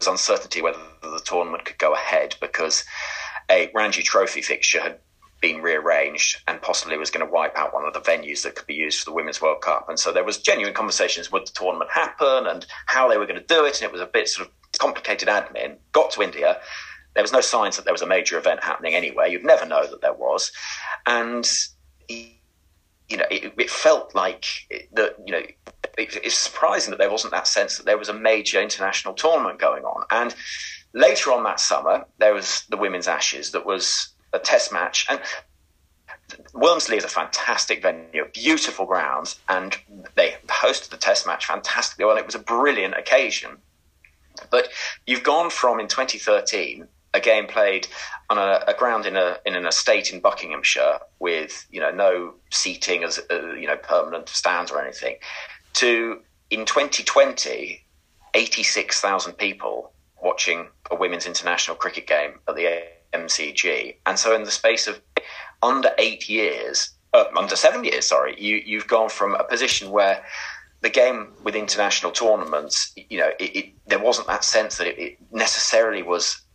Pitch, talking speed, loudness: 115 Hz, 180 wpm, -21 LUFS